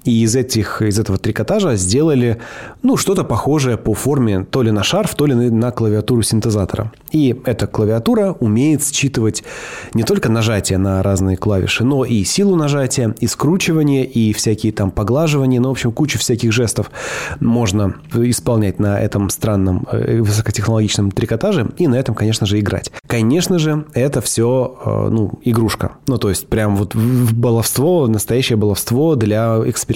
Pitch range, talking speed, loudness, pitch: 110-130 Hz, 155 wpm, -16 LUFS, 115 Hz